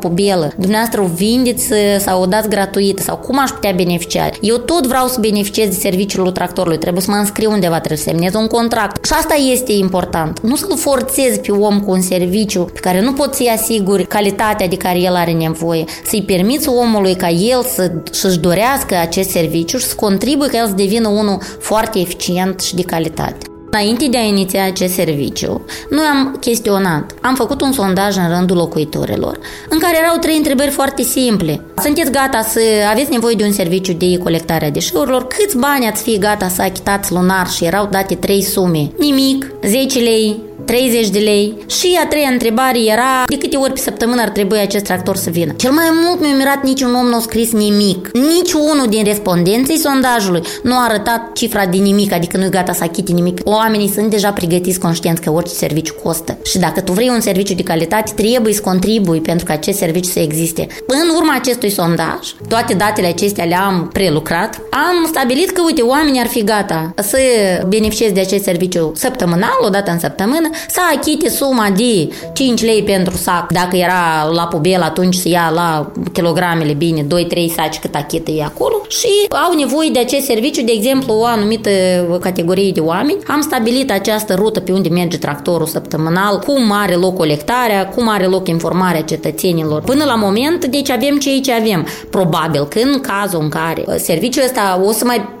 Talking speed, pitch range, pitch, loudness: 190 wpm, 180-245 Hz, 205 Hz, -14 LUFS